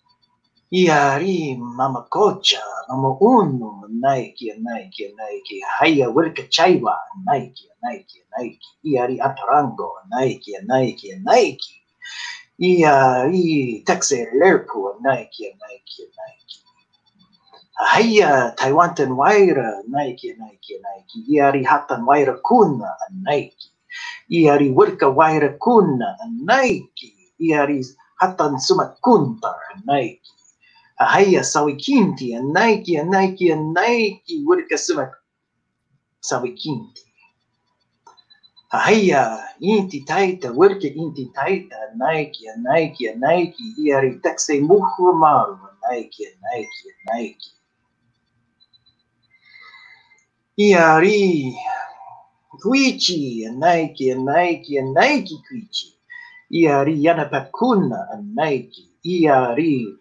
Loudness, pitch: -18 LUFS, 165 Hz